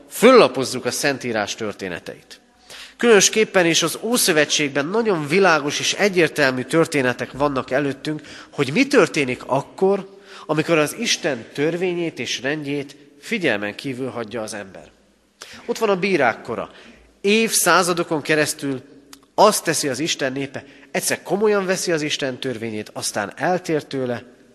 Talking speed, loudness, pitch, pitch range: 125 wpm, -19 LUFS, 150 Hz, 130-180 Hz